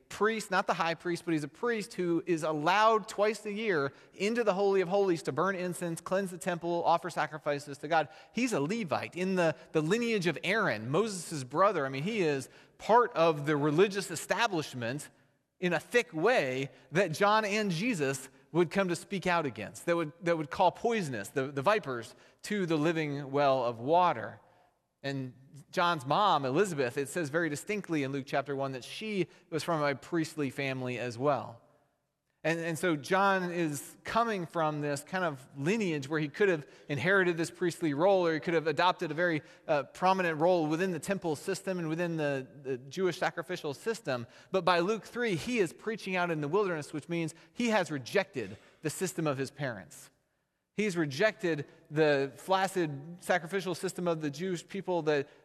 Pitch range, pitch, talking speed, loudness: 145-190 Hz, 170 Hz, 185 wpm, -31 LUFS